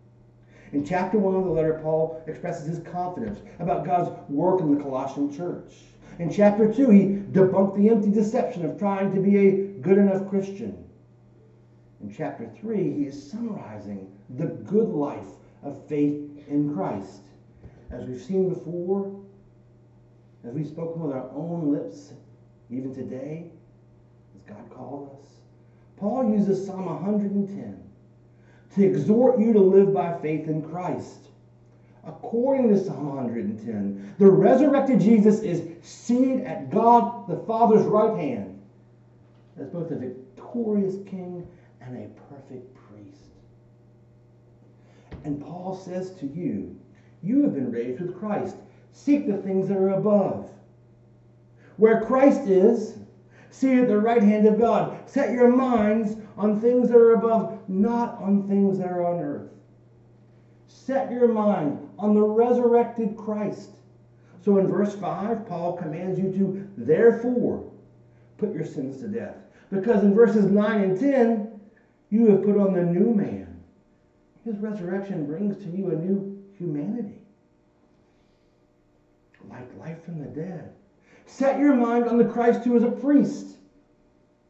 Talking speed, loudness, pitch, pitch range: 140 wpm, -23 LUFS, 185 Hz, 140-215 Hz